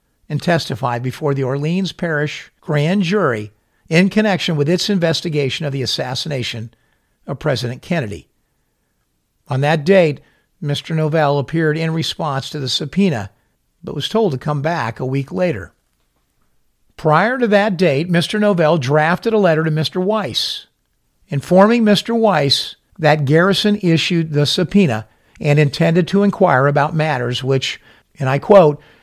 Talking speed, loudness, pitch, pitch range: 145 wpm, -16 LUFS, 155 Hz, 135-180 Hz